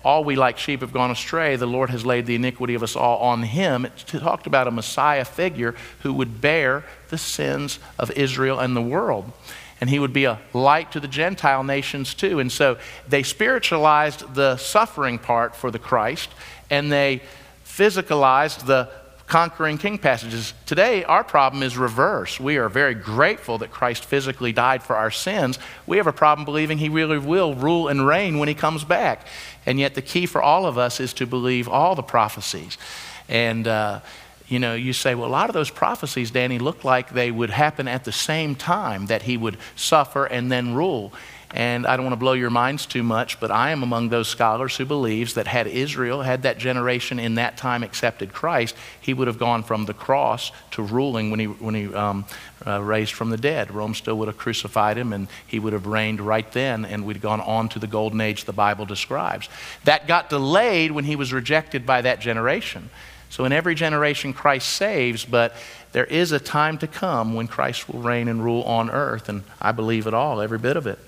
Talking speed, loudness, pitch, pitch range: 210 wpm, -22 LUFS, 125 Hz, 115-145 Hz